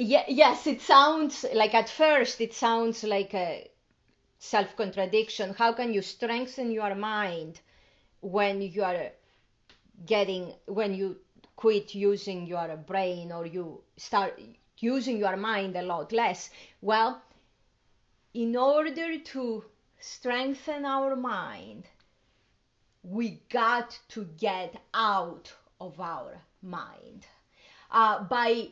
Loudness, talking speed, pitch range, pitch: -28 LUFS, 110 wpm, 195-245 Hz, 225 Hz